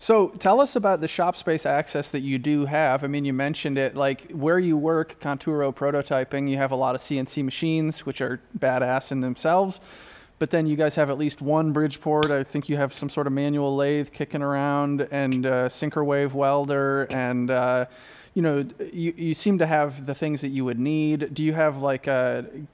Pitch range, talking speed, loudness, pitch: 135-155 Hz, 215 wpm, -24 LUFS, 145 Hz